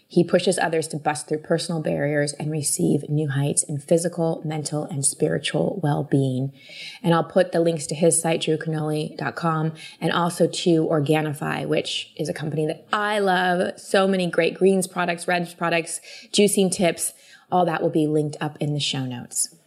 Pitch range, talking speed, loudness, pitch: 150-175 Hz, 175 wpm, -23 LUFS, 160 Hz